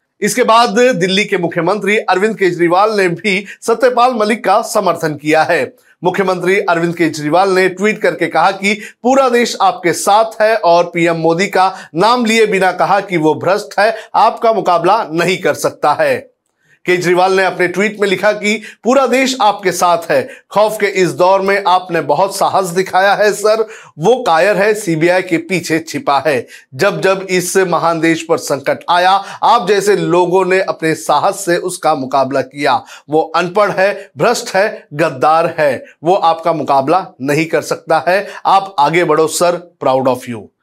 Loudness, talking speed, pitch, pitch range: -13 LUFS, 170 wpm, 185 Hz, 165-210 Hz